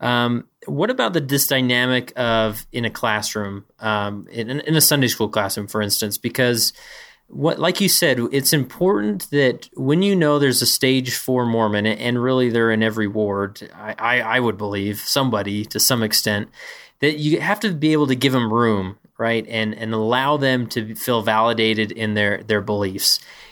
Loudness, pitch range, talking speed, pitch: -19 LUFS, 105-130 Hz, 185 wpm, 115 Hz